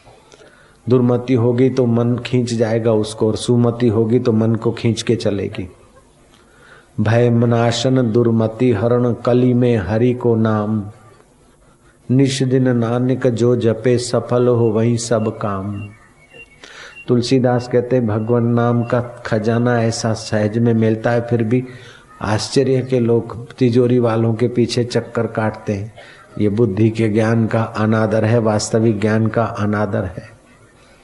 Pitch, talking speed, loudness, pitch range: 115 Hz, 135 wpm, -17 LUFS, 110-120 Hz